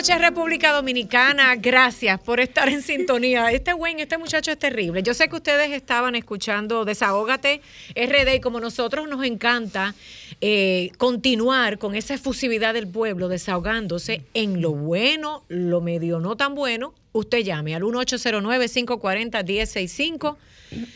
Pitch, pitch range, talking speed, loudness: 240 Hz, 210-275 Hz, 135 wpm, -21 LUFS